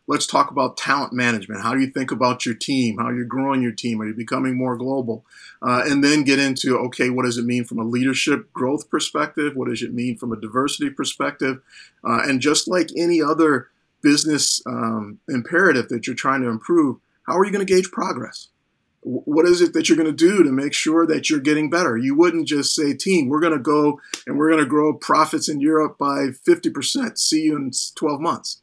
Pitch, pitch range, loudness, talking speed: 140 Hz, 125-160 Hz, -20 LUFS, 225 wpm